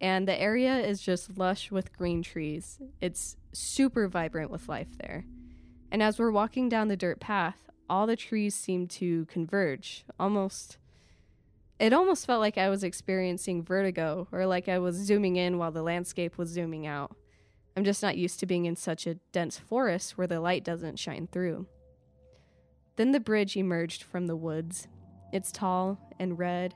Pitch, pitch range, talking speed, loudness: 180 Hz, 170-195 Hz, 175 wpm, -30 LUFS